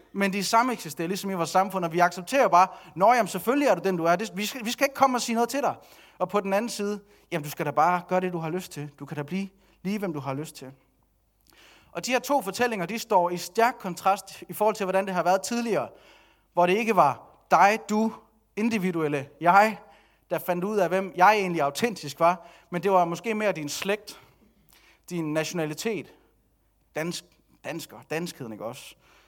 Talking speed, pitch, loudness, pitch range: 215 wpm, 185 Hz, -25 LUFS, 170-210 Hz